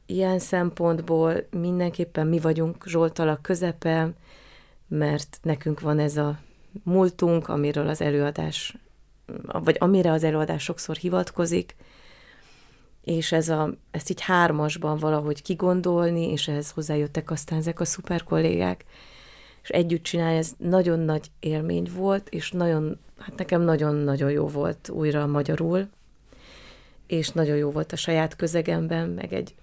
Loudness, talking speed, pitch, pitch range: -25 LUFS, 130 wpm, 160 Hz, 150-175 Hz